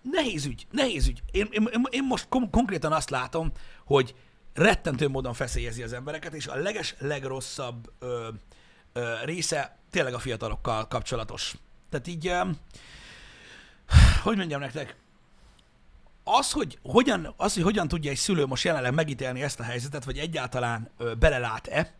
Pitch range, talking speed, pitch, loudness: 120-165 Hz, 140 wpm, 135 Hz, -27 LUFS